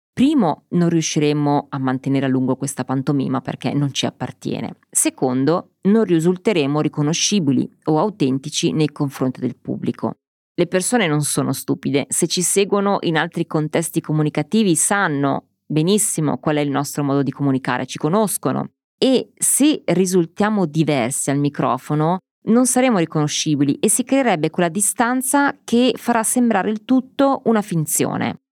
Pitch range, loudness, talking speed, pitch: 145-210 Hz, -19 LUFS, 140 wpm, 160 Hz